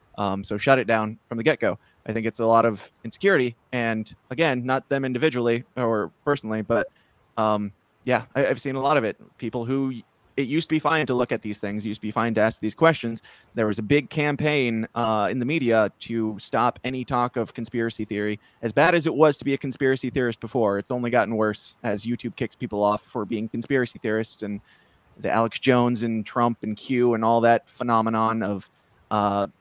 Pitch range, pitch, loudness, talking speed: 110-130 Hz, 115 Hz, -24 LUFS, 220 wpm